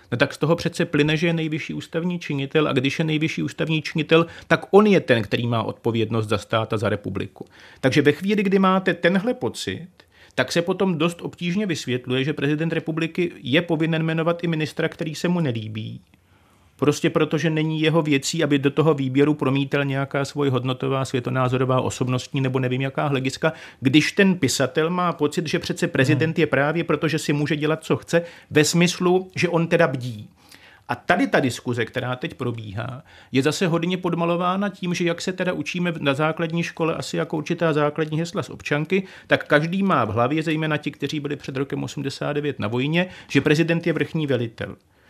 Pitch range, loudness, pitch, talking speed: 135-170 Hz, -22 LUFS, 155 Hz, 190 wpm